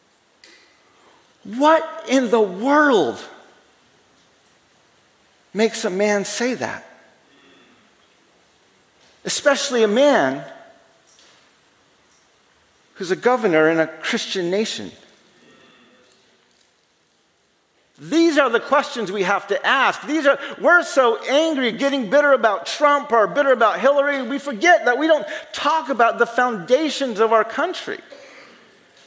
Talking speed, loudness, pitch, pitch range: 105 wpm, -18 LUFS, 270 Hz, 225-295 Hz